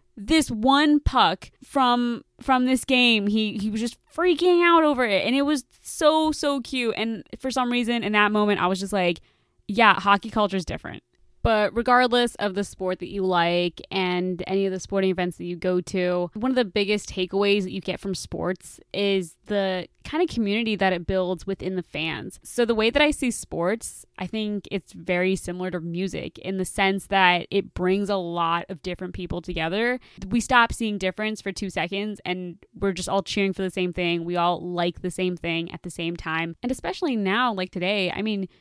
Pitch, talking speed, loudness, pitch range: 195 Hz, 210 wpm, -24 LUFS, 180-235 Hz